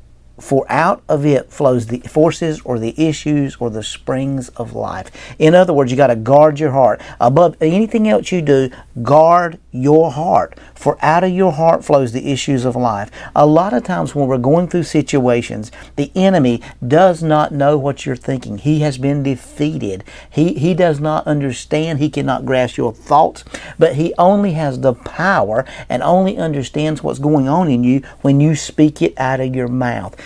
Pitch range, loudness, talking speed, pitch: 130-160 Hz, -15 LUFS, 185 wpm, 145 Hz